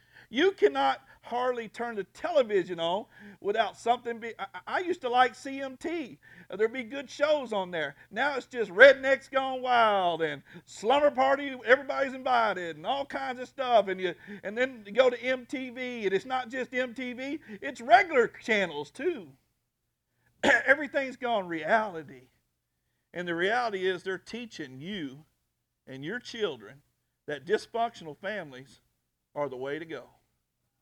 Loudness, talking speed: -28 LUFS, 150 wpm